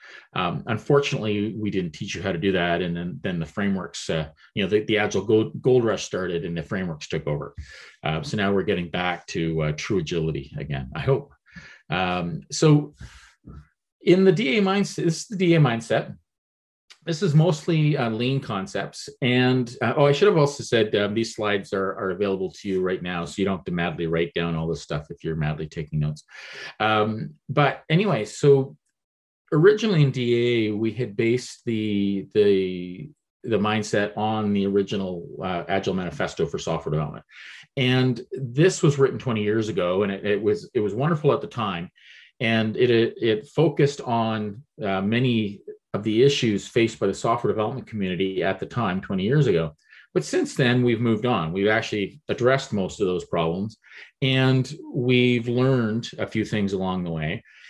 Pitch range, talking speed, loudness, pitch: 95-135 Hz, 185 wpm, -23 LUFS, 110 Hz